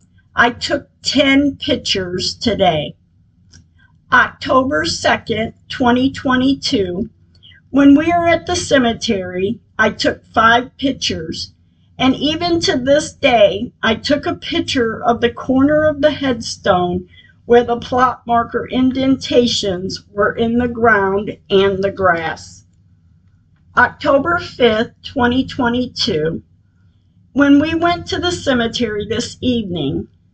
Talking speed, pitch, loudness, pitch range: 110 wpm, 240 Hz, -16 LUFS, 195-275 Hz